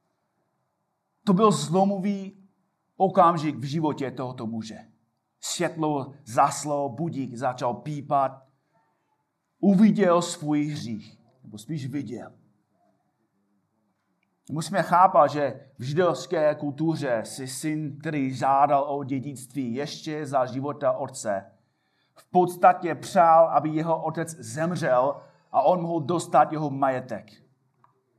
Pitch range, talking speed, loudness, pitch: 135-170 Hz, 100 wpm, -24 LUFS, 150 Hz